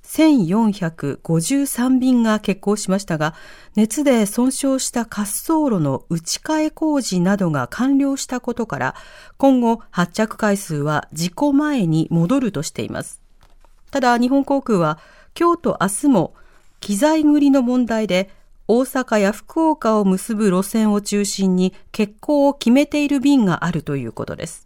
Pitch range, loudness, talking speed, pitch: 185-275 Hz, -18 LUFS, 265 characters per minute, 220 Hz